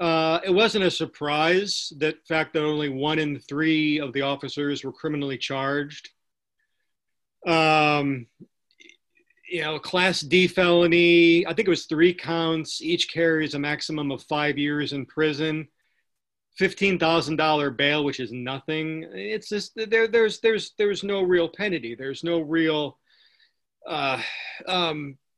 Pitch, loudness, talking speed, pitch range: 160 Hz, -23 LUFS, 135 wpm, 145-180 Hz